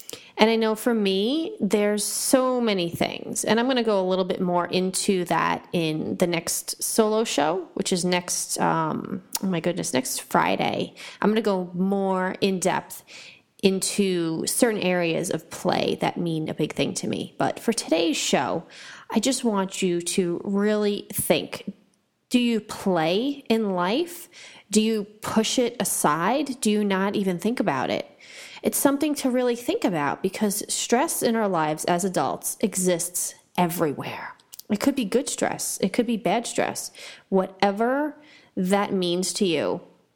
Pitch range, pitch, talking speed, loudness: 185-235 Hz, 205 Hz, 165 wpm, -24 LUFS